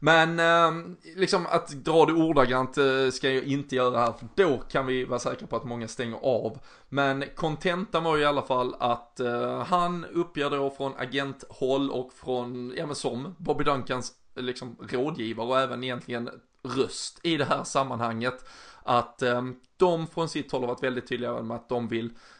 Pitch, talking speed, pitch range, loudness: 130 Hz, 180 wpm, 125-155 Hz, -27 LUFS